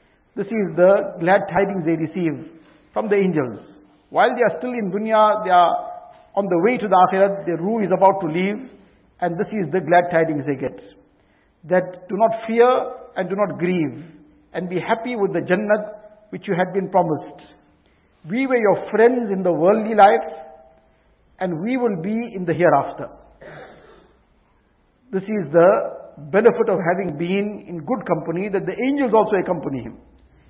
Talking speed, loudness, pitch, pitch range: 175 wpm, -19 LUFS, 190 Hz, 170-215 Hz